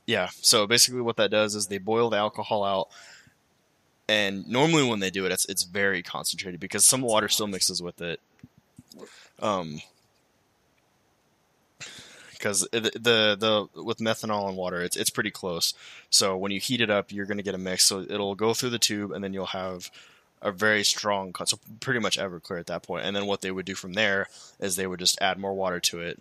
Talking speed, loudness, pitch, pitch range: 215 wpm, -25 LUFS, 100 Hz, 95-105 Hz